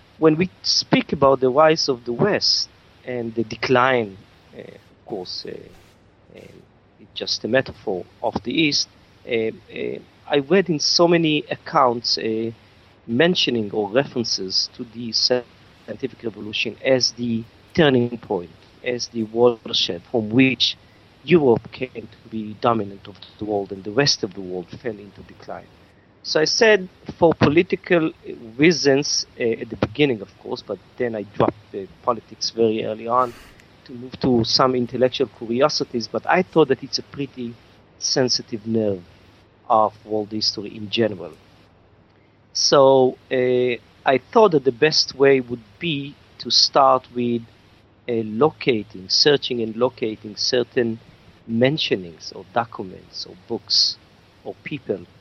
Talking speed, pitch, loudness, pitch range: 145 wpm, 115 Hz, -20 LUFS, 105-130 Hz